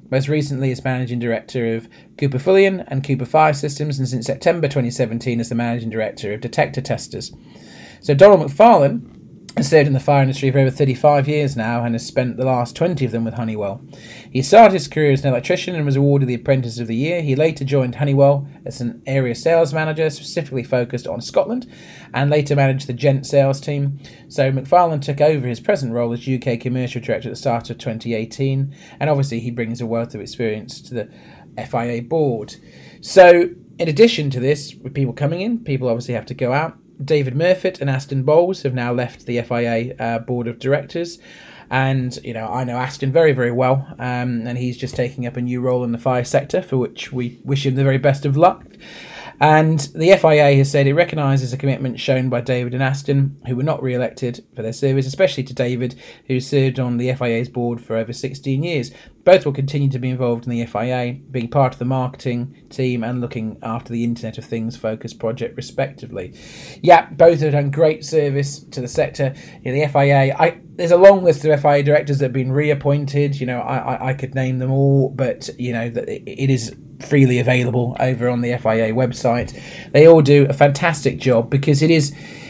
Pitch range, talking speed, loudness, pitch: 120-145 Hz, 205 wpm, -18 LUFS, 135 Hz